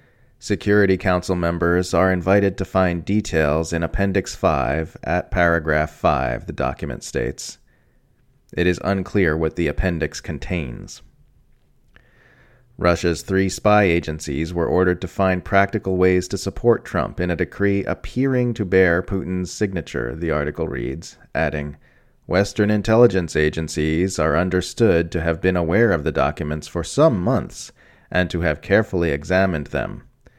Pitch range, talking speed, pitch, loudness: 80-100 Hz, 140 wpm, 90 Hz, -20 LUFS